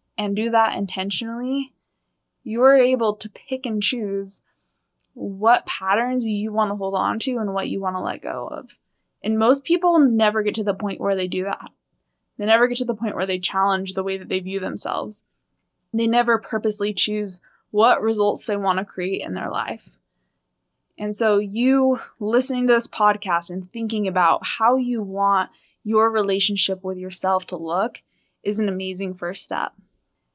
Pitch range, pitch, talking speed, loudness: 195-230 Hz, 210 Hz, 180 wpm, -22 LUFS